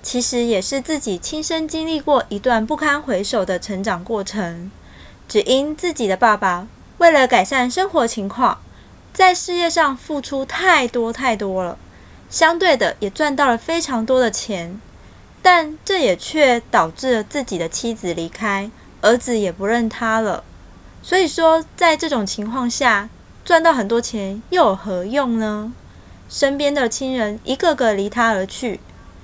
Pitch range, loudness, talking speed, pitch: 210-305 Hz, -18 LUFS, 230 characters per minute, 245 Hz